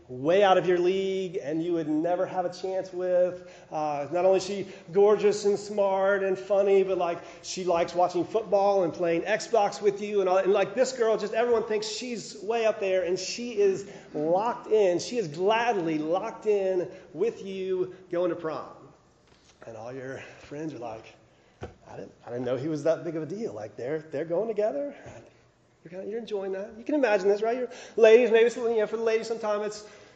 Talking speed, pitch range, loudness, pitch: 210 wpm, 175-210 Hz, -26 LUFS, 190 Hz